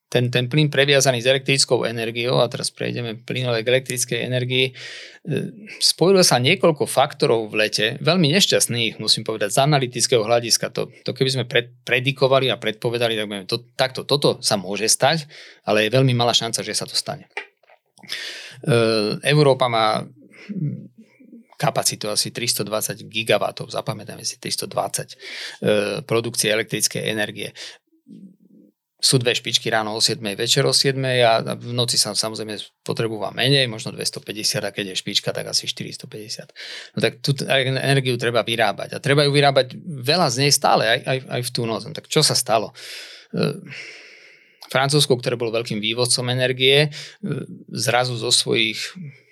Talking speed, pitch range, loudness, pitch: 145 wpm, 115-145 Hz, -20 LUFS, 125 Hz